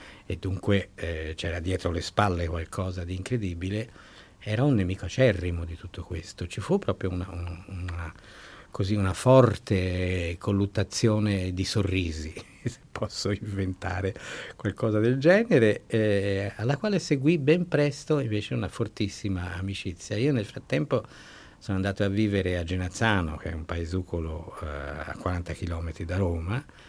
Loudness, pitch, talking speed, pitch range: -28 LUFS, 95 Hz, 145 wpm, 90-105 Hz